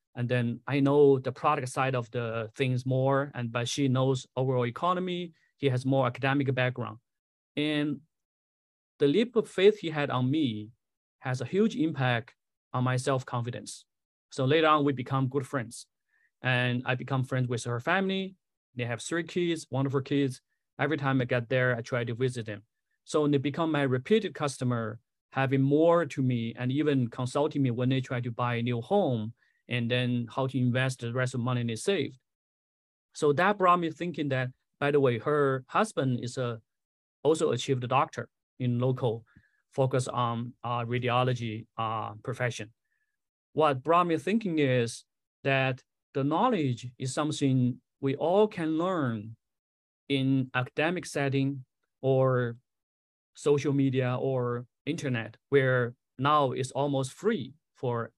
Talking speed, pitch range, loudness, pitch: 160 wpm, 120-145 Hz, -29 LUFS, 130 Hz